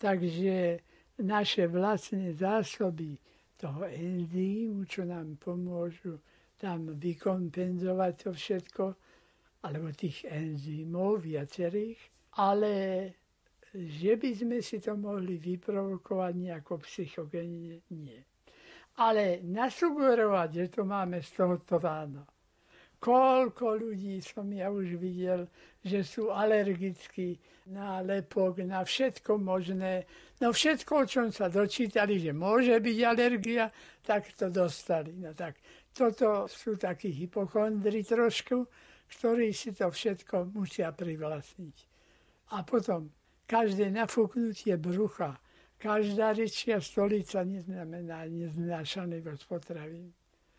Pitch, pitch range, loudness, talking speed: 190 Hz, 175-215 Hz, -32 LUFS, 100 wpm